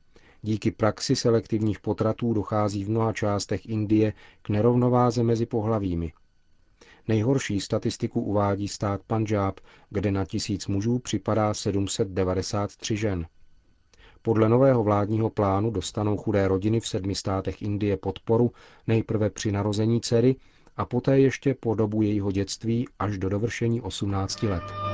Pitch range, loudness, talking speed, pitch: 100-115 Hz, -26 LUFS, 130 wpm, 105 Hz